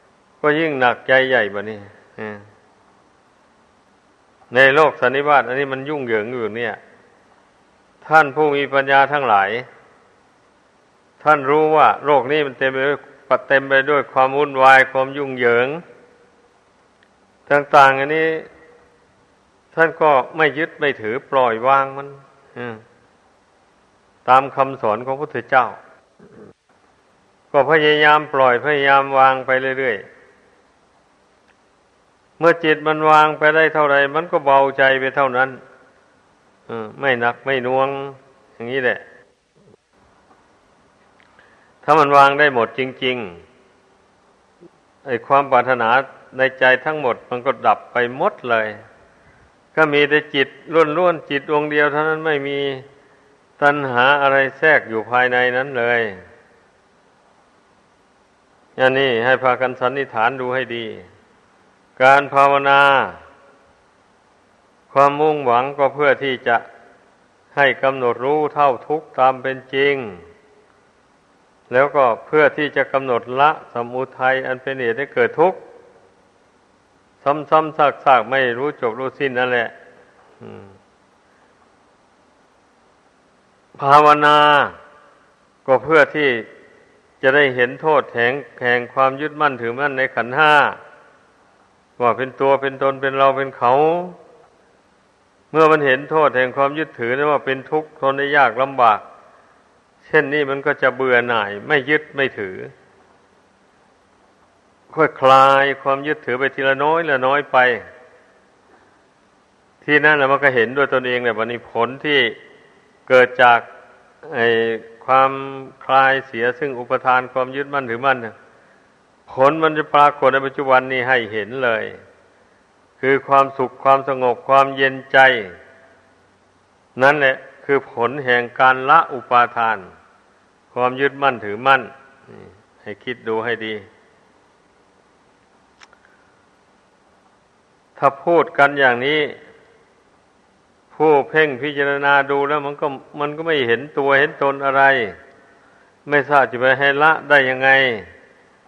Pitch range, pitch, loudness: 125-145 Hz, 135 Hz, -16 LUFS